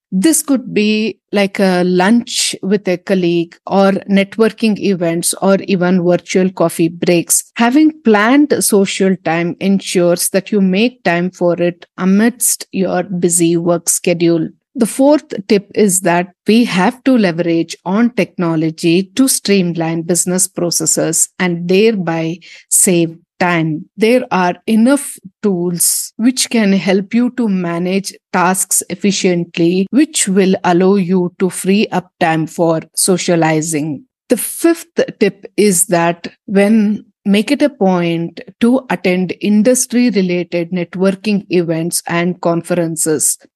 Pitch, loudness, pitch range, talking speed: 190 Hz, -13 LUFS, 175-215 Hz, 125 wpm